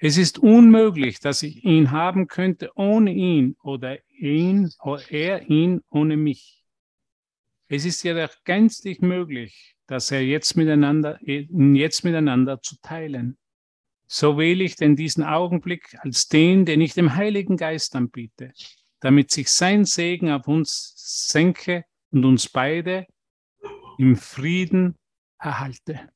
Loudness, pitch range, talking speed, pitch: -20 LUFS, 140-180 Hz, 130 wpm, 155 Hz